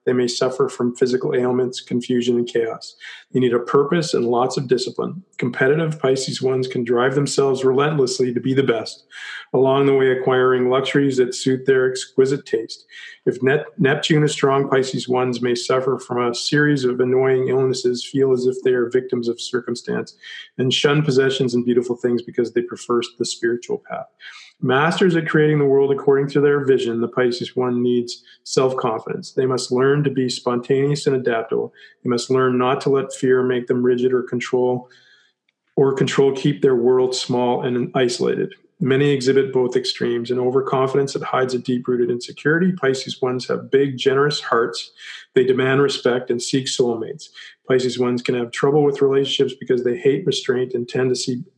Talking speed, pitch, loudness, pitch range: 175 wpm, 130 Hz, -19 LUFS, 125-140 Hz